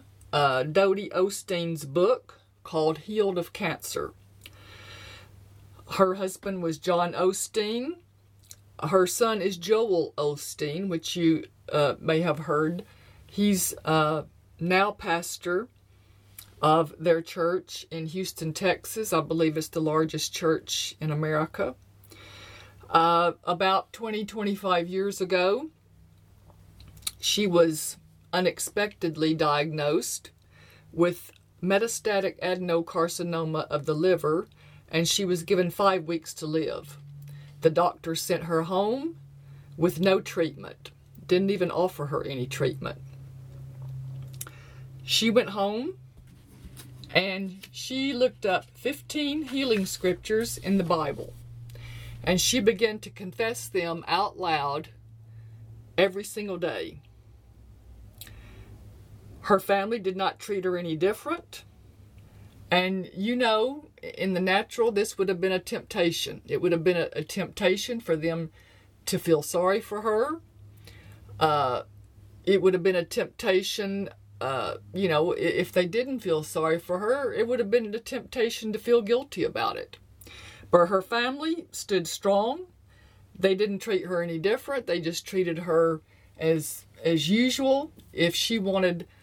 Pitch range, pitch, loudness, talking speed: 130-195 Hz, 170 Hz, -27 LUFS, 125 wpm